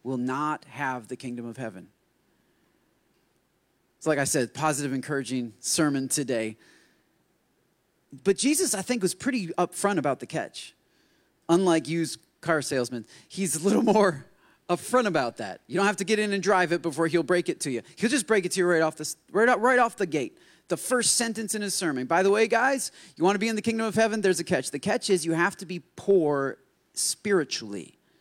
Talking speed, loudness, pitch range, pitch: 210 wpm, -26 LUFS, 145-205 Hz, 175 Hz